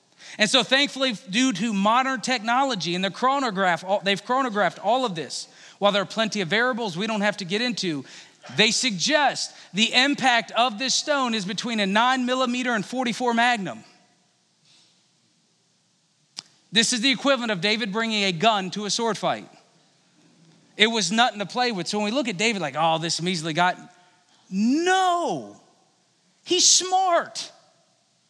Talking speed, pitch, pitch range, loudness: 160 wpm, 225 Hz, 195-255 Hz, -22 LUFS